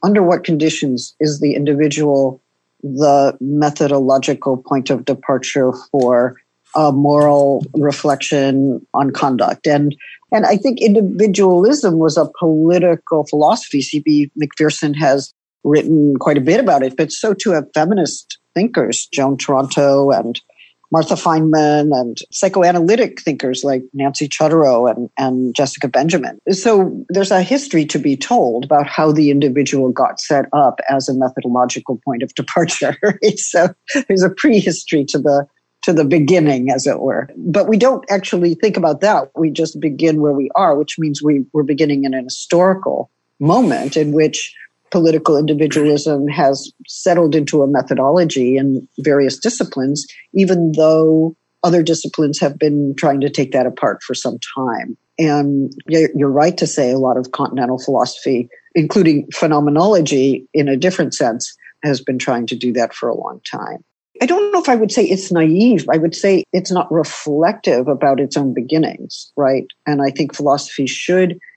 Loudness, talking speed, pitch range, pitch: -15 LUFS, 155 wpm, 140-170 Hz, 150 Hz